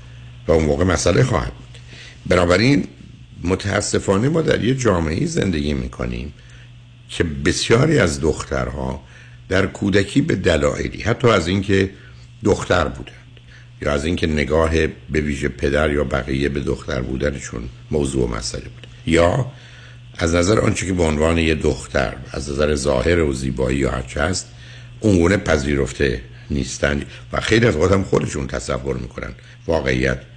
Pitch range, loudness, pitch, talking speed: 65-105 Hz, -19 LUFS, 80 Hz, 140 wpm